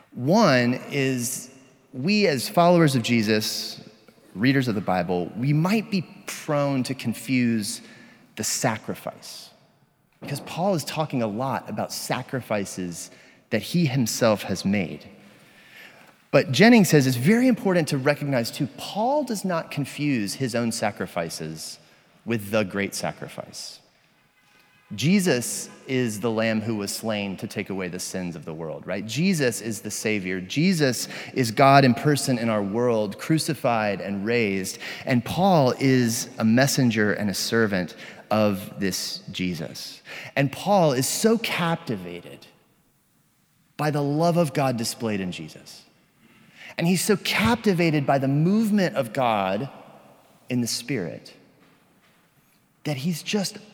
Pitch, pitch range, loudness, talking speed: 130 Hz, 105-155 Hz, -23 LUFS, 135 wpm